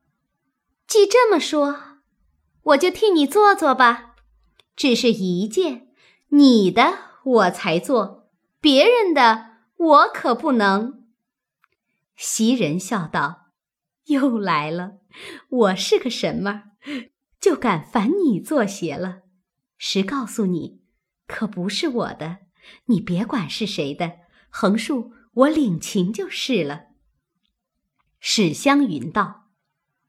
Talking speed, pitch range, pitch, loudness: 145 characters per minute, 190-280 Hz, 230 Hz, -19 LUFS